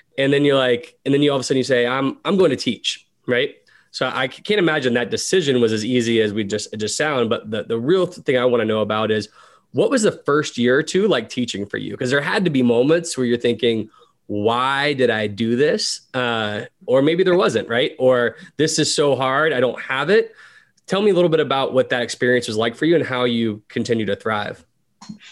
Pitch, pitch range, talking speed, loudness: 130 Hz, 115-155 Hz, 250 wpm, -19 LUFS